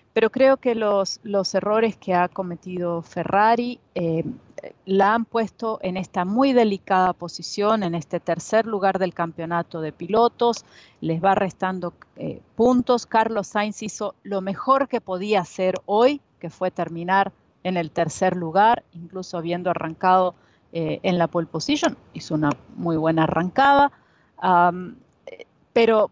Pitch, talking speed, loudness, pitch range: 190 Hz, 145 wpm, -22 LUFS, 170-220 Hz